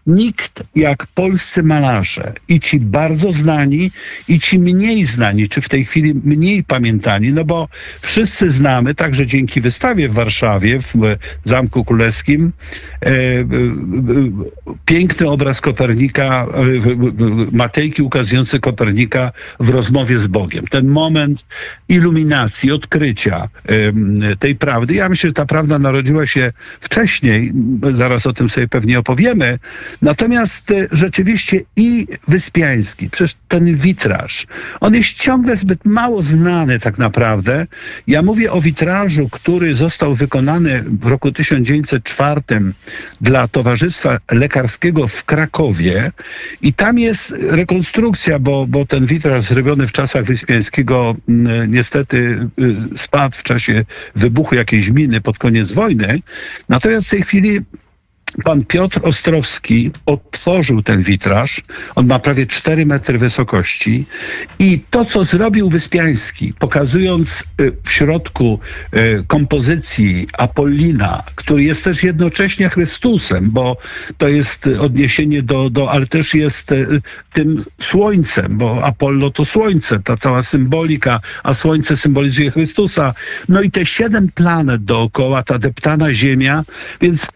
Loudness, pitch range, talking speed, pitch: -13 LUFS, 120-165 Hz, 120 wpm, 140 Hz